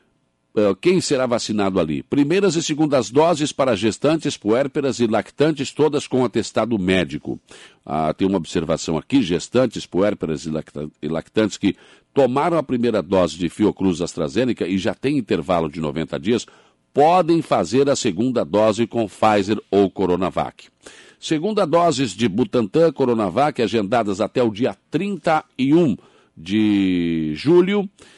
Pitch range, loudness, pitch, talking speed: 95-150 Hz, -20 LUFS, 115 Hz, 130 wpm